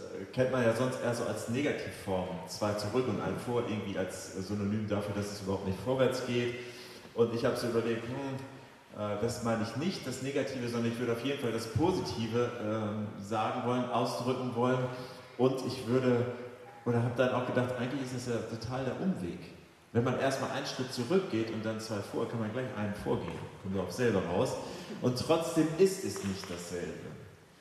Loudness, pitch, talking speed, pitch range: -33 LUFS, 120 Hz, 195 wpm, 105-130 Hz